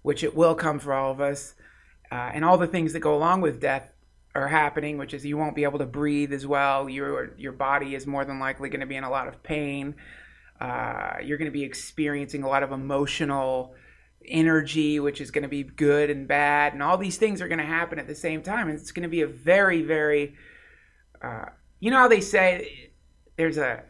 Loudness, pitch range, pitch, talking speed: -25 LUFS, 140-160 Hz, 145 Hz, 230 wpm